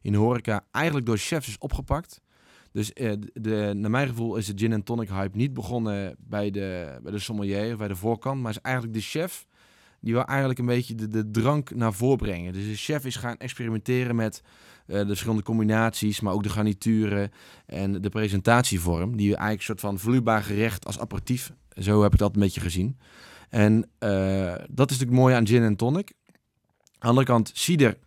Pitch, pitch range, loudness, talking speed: 110 Hz, 100-120 Hz, -26 LUFS, 190 wpm